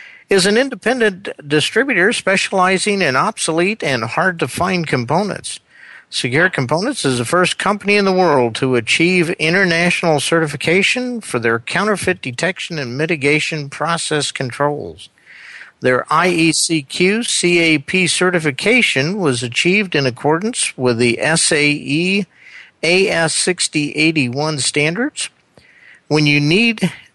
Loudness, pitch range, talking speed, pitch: -15 LUFS, 145-190 Hz, 110 wpm, 165 Hz